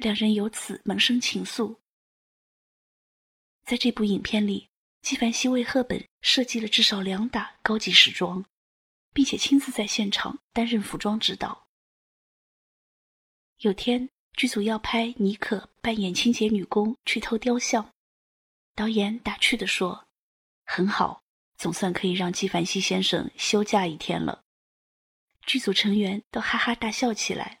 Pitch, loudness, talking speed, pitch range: 215 Hz, -25 LUFS, 210 characters per minute, 200-235 Hz